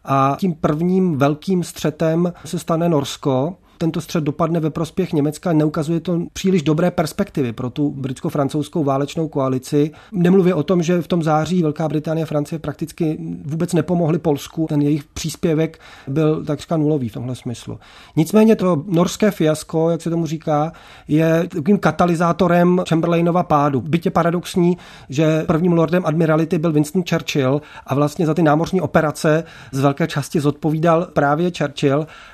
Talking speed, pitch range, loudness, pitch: 150 wpm, 150-175 Hz, -19 LUFS, 160 Hz